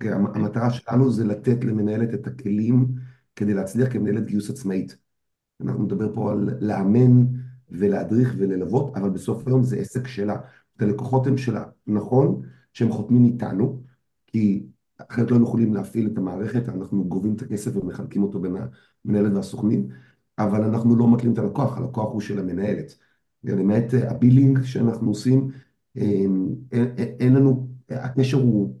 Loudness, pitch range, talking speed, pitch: -22 LUFS, 100-125 Hz, 145 wpm, 110 Hz